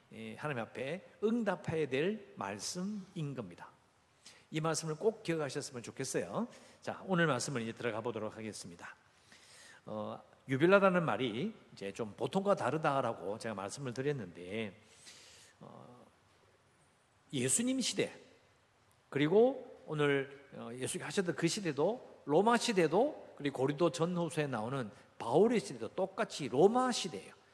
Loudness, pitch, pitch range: -35 LUFS, 150 Hz, 120-190 Hz